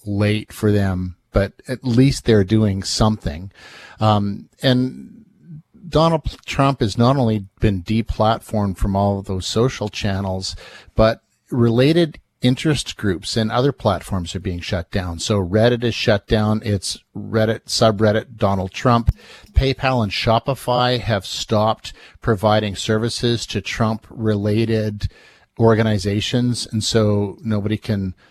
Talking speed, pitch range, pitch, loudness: 125 wpm, 100-120 Hz, 110 Hz, -19 LUFS